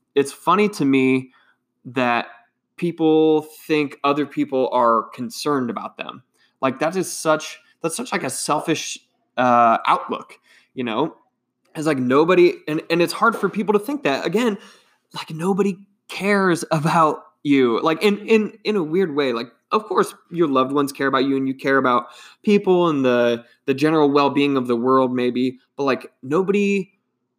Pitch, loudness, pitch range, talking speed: 155 Hz, -20 LUFS, 130-185 Hz, 170 wpm